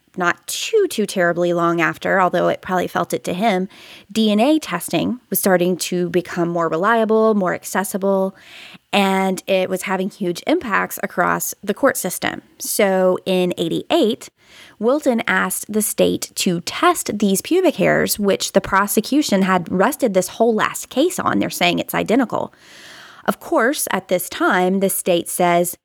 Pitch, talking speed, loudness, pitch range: 195 Hz, 155 wpm, -18 LUFS, 185-230 Hz